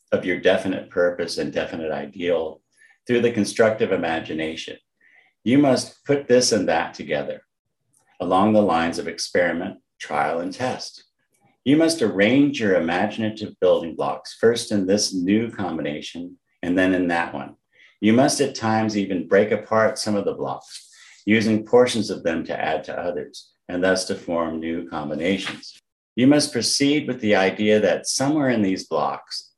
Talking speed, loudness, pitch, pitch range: 160 wpm, -21 LUFS, 110 Hz, 95-140 Hz